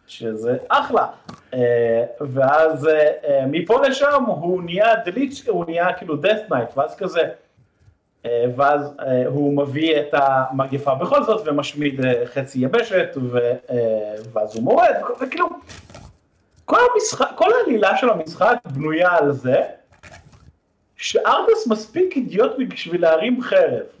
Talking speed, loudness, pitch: 125 wpm, -19 LUFS, 160 Hz